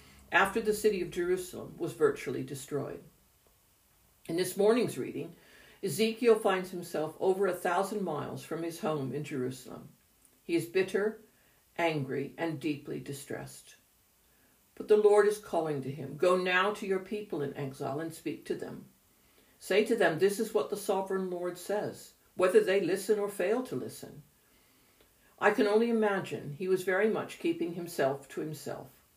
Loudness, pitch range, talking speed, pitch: -31 LUFS, 160-210 Hz, 160 wpm, 185 Hz